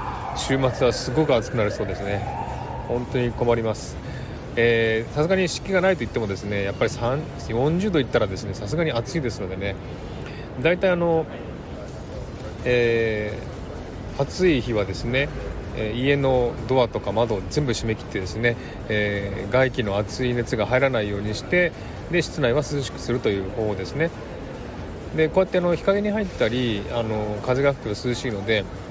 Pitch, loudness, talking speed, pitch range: 120 Hz, -23 LUFS, 325 characters per minute, 105-135 Hz